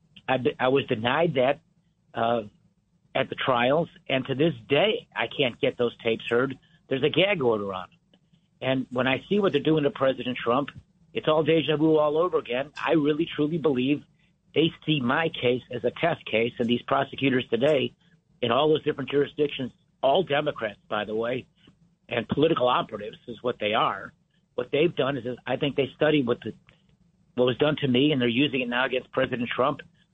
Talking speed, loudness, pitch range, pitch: 195 wpm, -25 LUFS, 125-155 Hz, 135 Hz